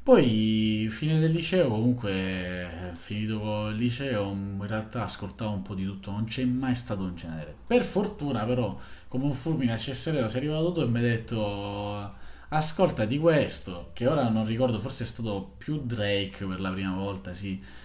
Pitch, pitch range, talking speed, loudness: 110 Hz, 100-130 Hz, 180 wpm, -28 LUFS